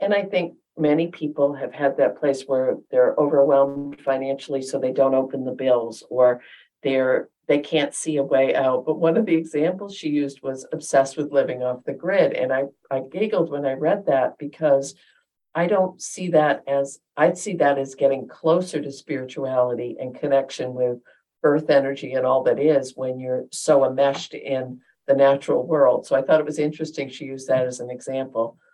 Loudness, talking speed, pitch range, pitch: -22 LUFS, 190 wpm, 130-150 Hz, 140 Hz